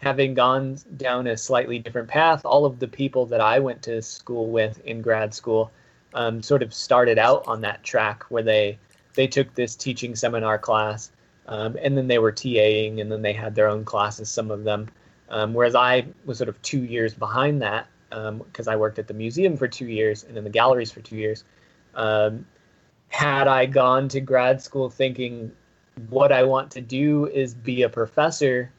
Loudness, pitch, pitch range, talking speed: -22 LUFS, 120 Hz, 110-130 Hz, 200 wpm